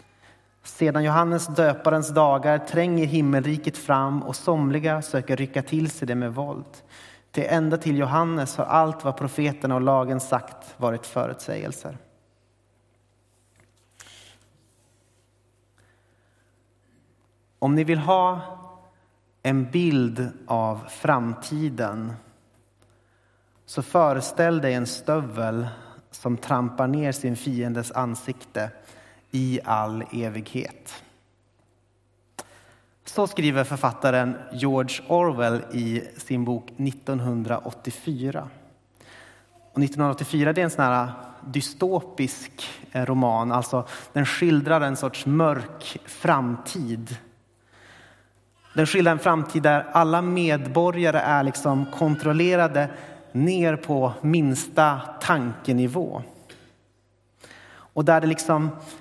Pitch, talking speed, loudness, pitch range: 130 Hz, 95 wpm, -24 LUFS, 115-150 Hz